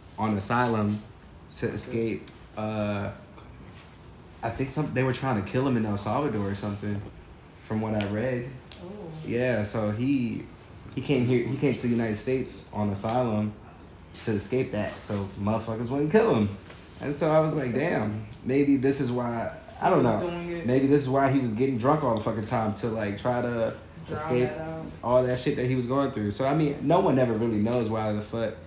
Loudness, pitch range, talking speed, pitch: -27 LUFS, 105-130 Hz, 195 wpm, 115 Hz